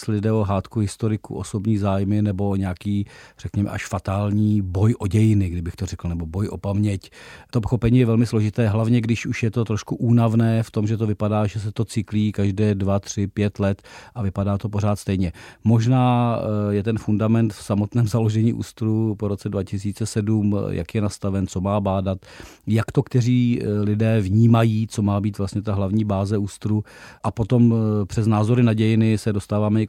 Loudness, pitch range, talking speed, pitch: -21 LUFS, 100-115 Hz, 185 wpm, 105 Hz